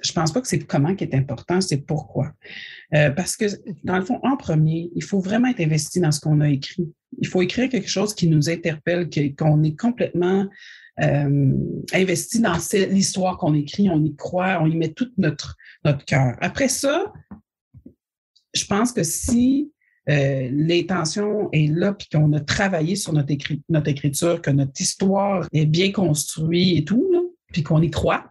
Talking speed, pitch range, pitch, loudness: 180 wpm, 150-195 Hz, 170 Hz, -21 LUFS